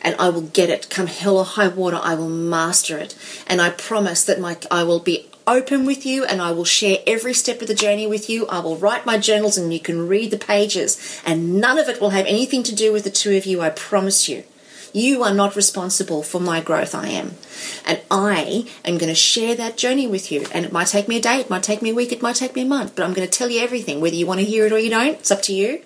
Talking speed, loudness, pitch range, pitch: 285 wpm, -18 LUFS, 180-230 Hz, 200 Hz